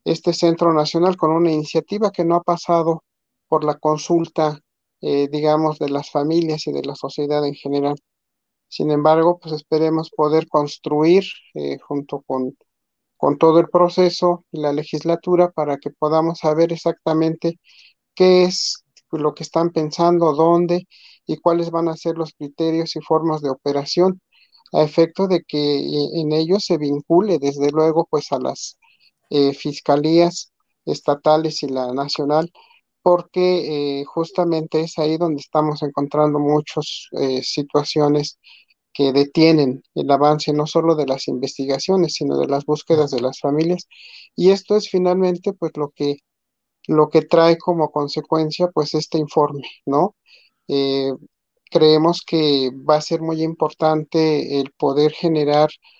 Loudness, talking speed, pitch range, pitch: -19 LUFS, 145 wpm, 145-170 Hz, 155 Hz